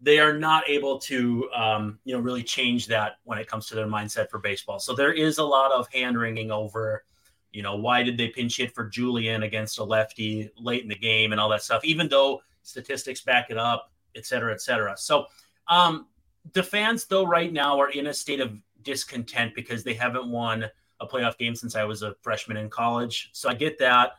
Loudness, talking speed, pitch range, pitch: -25 LUFS, 220 wpm, 110-135 Hz, 120 Hz